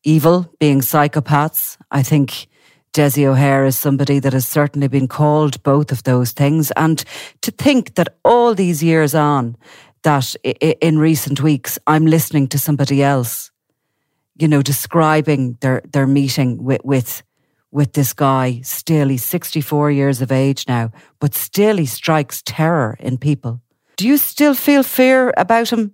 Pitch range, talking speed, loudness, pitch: 135-155 Hz, 155 wpm, -15 LUFS, 145 Hz